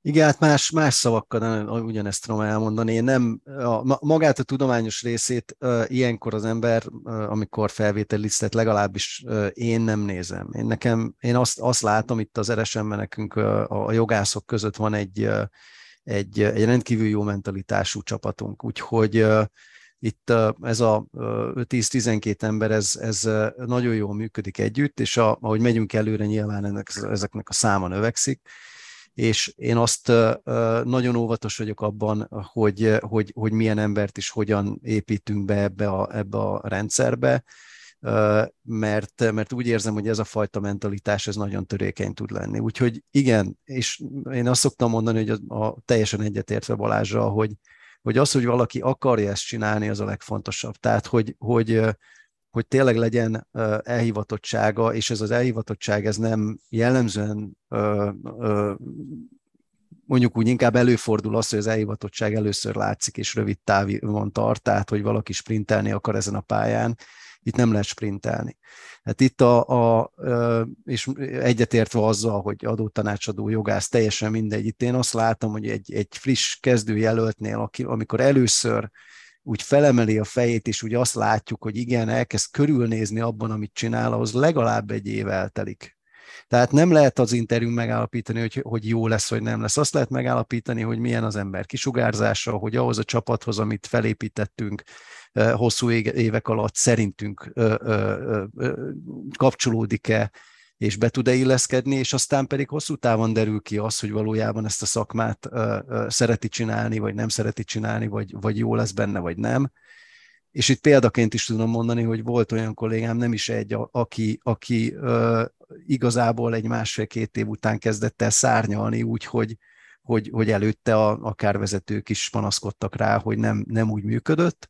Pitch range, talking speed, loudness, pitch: 105-120 Hz, 160 wpm, -23 LUFS, 110 Hz